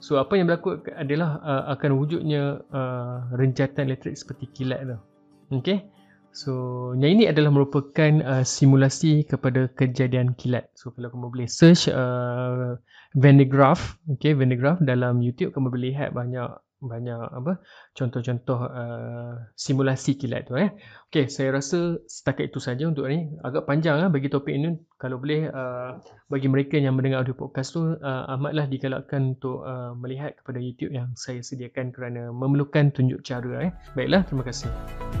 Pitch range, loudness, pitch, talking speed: 125-145 Hz, -24 LUFS, 135 Hz, 165 wpm